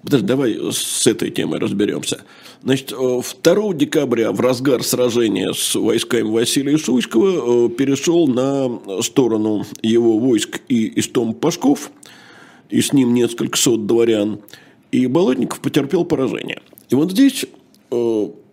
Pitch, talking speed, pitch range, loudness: 130 Hz, 120 wpm, 115-155 Hz, -17 LUFS